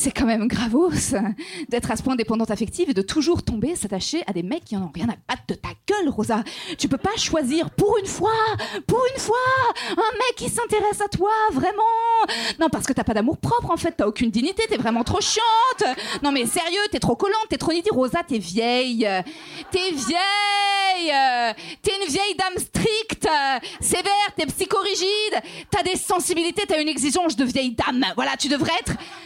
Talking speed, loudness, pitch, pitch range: 200 wpm, -22 LUFS, 335 Hz, 255-405 Hz